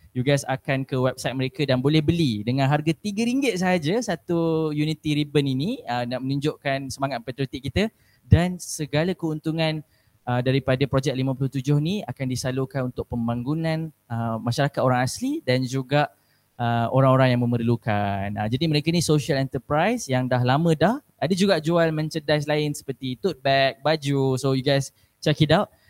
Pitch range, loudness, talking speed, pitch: 130-160 Hz, -23 LUFS, 160 wpm, 140 Hz